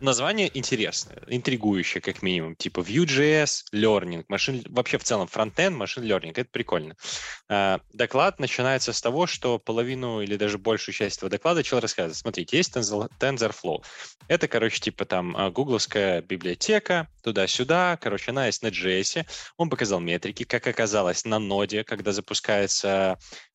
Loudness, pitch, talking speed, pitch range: -25 LUFS, 110 Hz, 140 wpm, 100-130 Hz